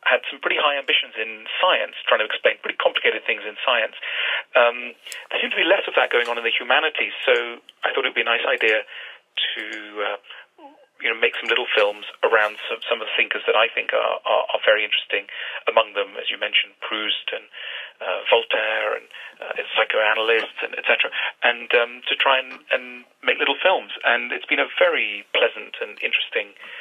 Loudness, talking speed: -21 LUFS, 200 wpm